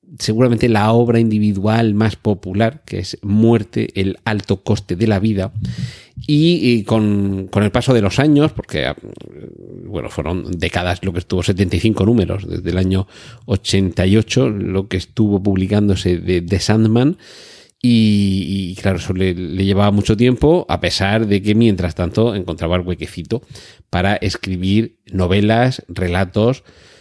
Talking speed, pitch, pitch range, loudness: 145 wpm, 105 Hz, 95-115 Hz, -16 LUFS